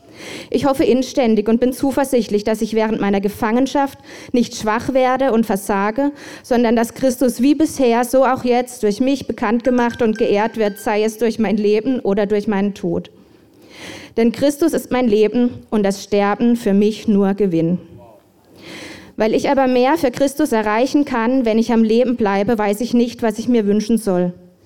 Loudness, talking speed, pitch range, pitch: -17 LUFS, 180 wpm, 210-255 Hz, 230 Hz